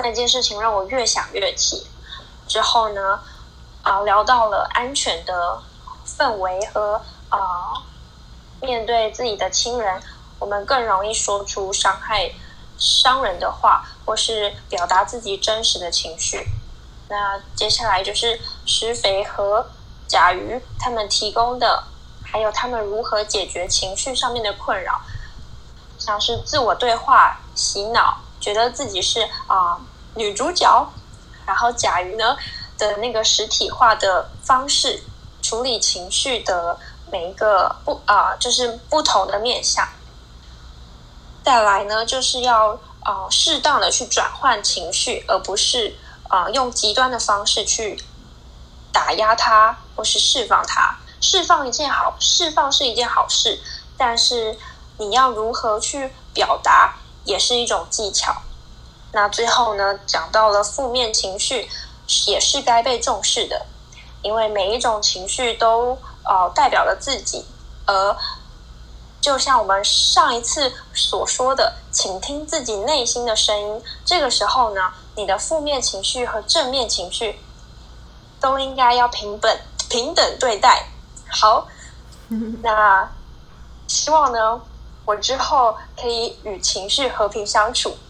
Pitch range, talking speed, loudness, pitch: 200-250 Hz, 200 characters per minute, -18 LUFS, 220 Hz